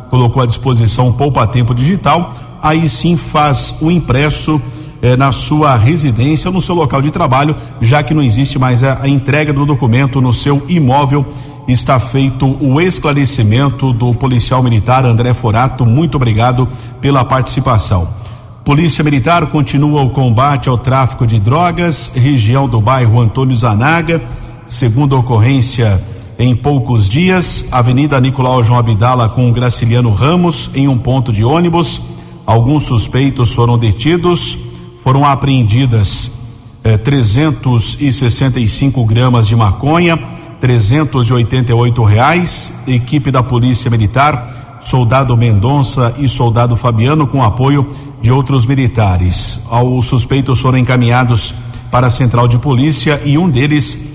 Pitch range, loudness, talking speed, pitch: 120-140 Hz, -11 LUFS, 130 wpm, 130 Hz